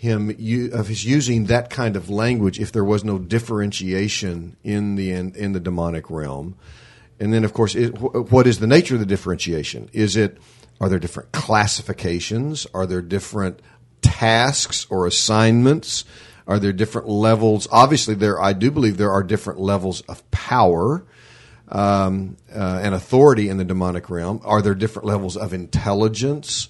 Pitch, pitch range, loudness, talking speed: 105 Hz, 95-115 Hz, -19 LUFS, 165 wpm